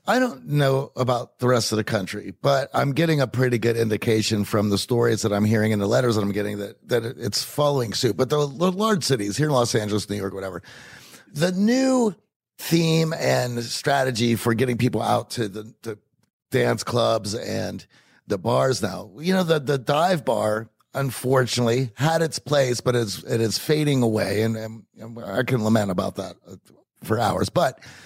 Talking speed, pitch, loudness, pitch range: 190 wpm, 120 Hz, -22 LUFS, 110-140 Hz